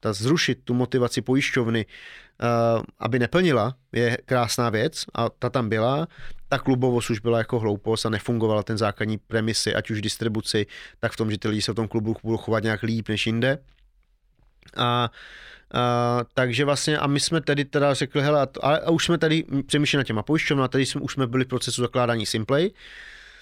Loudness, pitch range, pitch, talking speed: -24 LUFS, 115-140 Hz, 120 Hz, 185 wpm